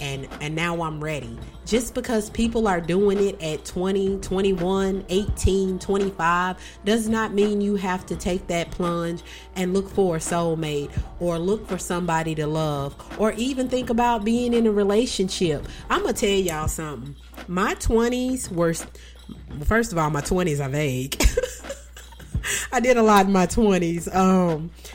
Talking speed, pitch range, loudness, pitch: 165 wpm, 165-210 Hz, -23 LUFS, 185 Hz